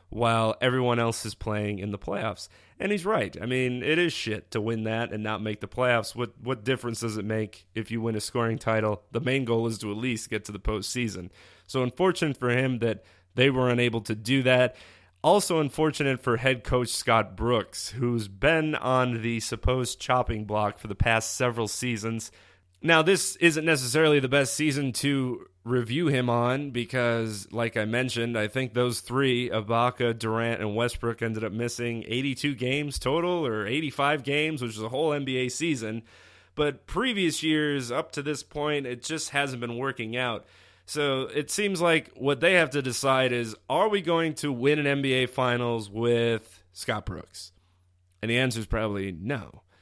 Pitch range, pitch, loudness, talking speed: 110-135 Hz, 120 Hz, -27 LUFS, 185 wpm